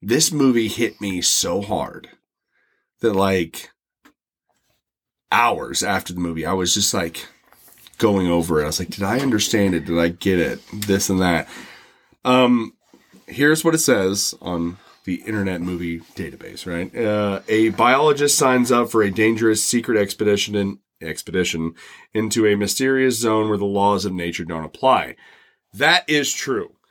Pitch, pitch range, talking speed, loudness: 100 Hz, 90-115 Hz, 155 wpm, -19 LUFS